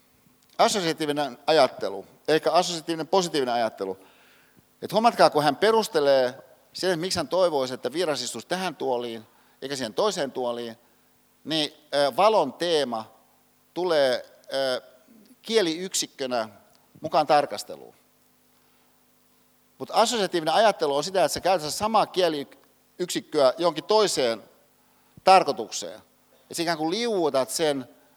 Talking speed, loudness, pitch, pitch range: 100 wpm, -24 LUFS, 155 Hz, 130-185 Hz